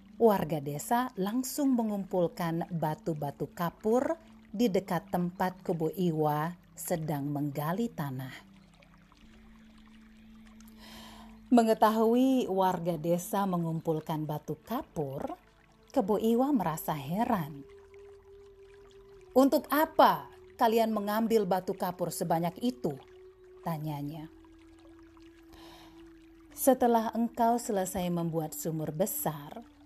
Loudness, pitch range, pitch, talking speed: -30 LUFS, 170-255 Hz, 215 Hz, 75 wpm